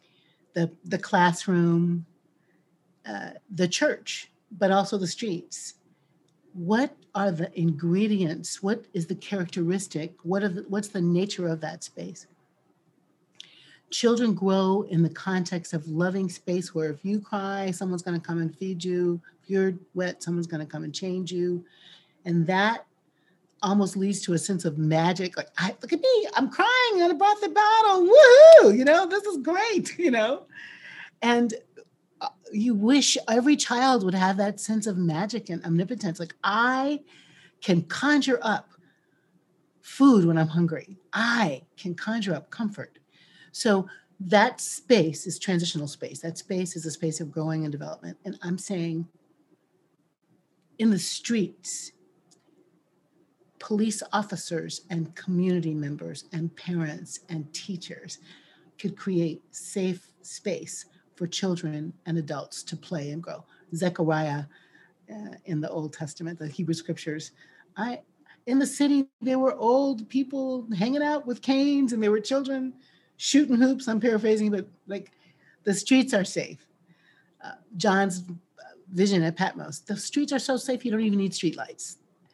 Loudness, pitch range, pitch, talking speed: -24 LUFS, 170-220 Hz, 185 Hz, 150 wpm